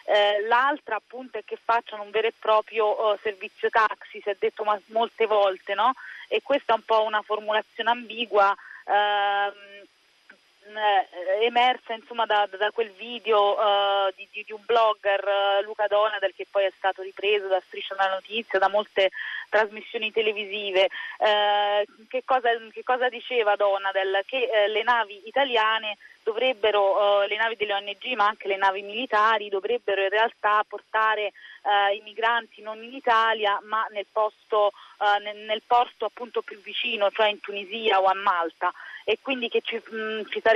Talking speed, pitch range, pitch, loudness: 165 wpm, 200-225 Hz, 215 Hz, -24 LUFS